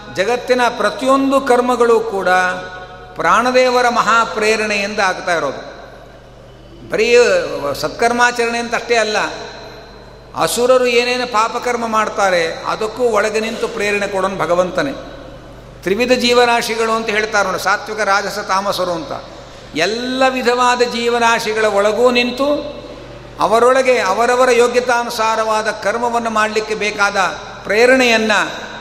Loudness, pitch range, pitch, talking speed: -15 LUFS, 205-245 Hz, 225 Hz, 90 wpm